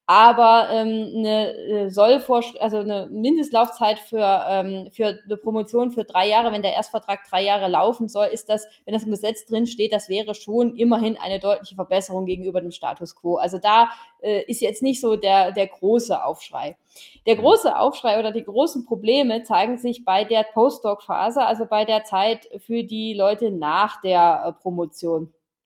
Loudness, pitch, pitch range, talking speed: -21 LUFS, 215 Hz, 195-230 Hz, 175 wpm